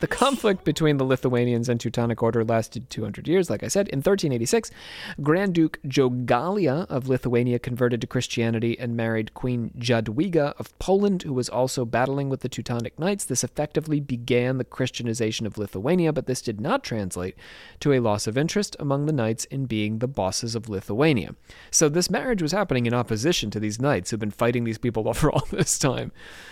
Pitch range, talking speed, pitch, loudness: 115-150 Hz, 190 wpm, 125 Hz, -24 LUFS